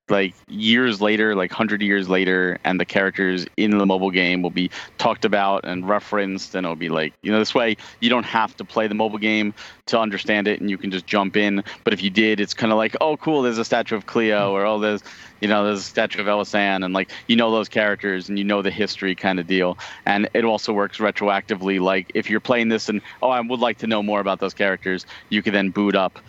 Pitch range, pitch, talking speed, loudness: 95-110 Hz, 105 Hz, 250 wpm, -21 LUFS